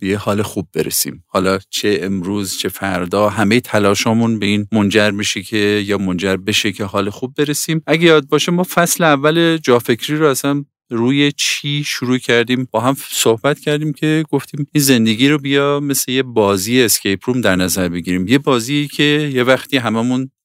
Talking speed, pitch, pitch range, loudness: 175 wpm, 125 Hz, 105-145 Hz, -15 LUFS